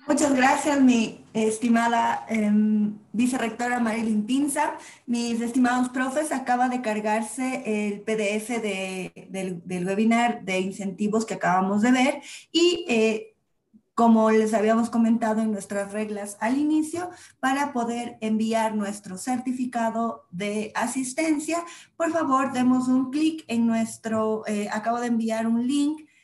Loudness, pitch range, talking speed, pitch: -24 LUFS, 215-260 Hz, 130 wpm, 230 Hz